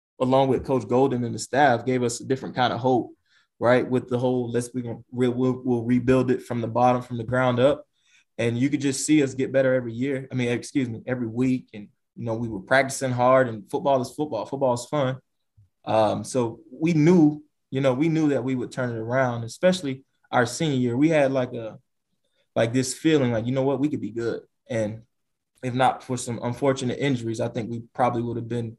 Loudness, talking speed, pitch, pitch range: -24 LUFS, 225 wpm, 125 Hz, 120-135 Hz